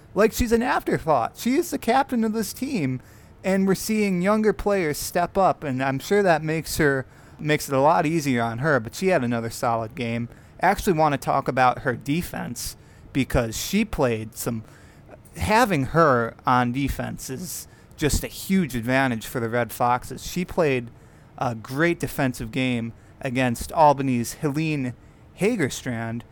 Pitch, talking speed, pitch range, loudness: 135 Hz, 165 wpm, 120-170 Hz, -23 LUFS